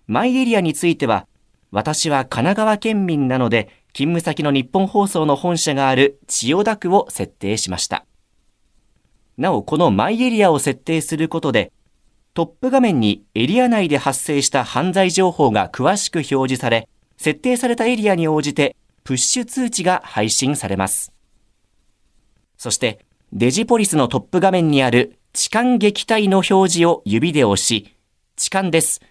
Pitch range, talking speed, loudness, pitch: 125-190 Hz, 305 characters per minute, -17 LUFS, 155 Hz